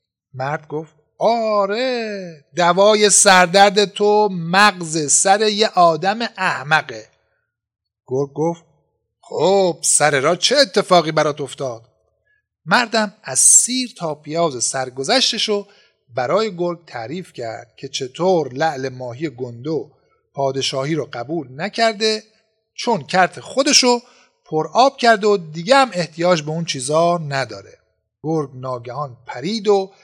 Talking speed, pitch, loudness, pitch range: 115 wpm, 170 Hz, -17 LUFS, 140-210 Hz